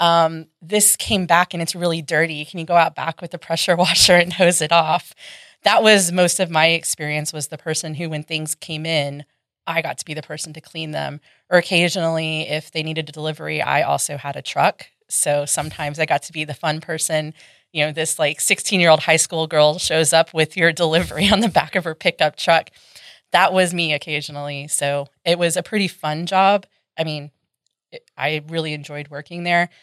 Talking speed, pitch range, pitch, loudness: 215 wpm, 155-175 Hz, 160 Hz, -18 LUFS